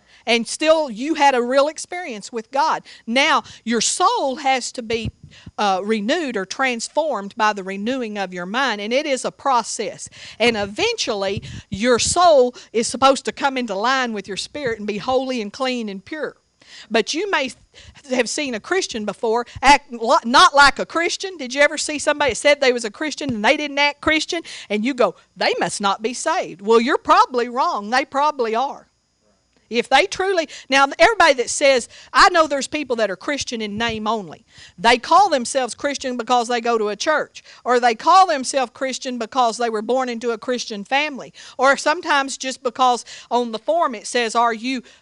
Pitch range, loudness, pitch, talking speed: 230-290 Hz, -19 LUFS, 255 Hz, 195 wpm